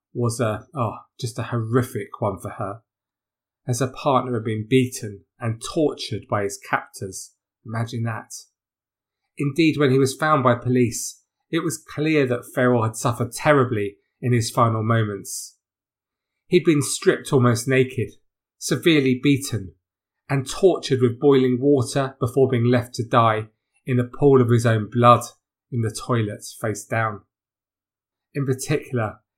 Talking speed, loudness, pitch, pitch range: 145 wpm, -21 LUFS, 125 Hz, 110-135 Hz